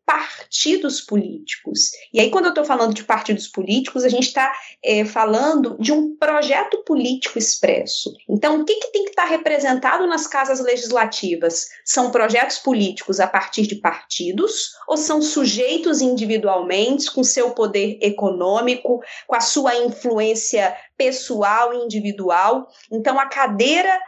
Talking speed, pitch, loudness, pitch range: 145 wpm, 250 Hz, -19 LUFS, 215-300 Hz